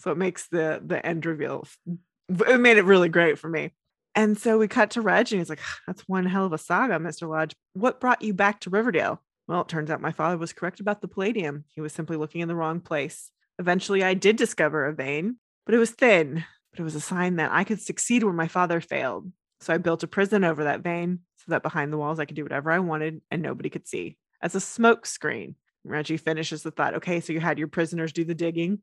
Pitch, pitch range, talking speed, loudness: 170 Hz, 160-200 Hz, 250 wpm, -25 LUFS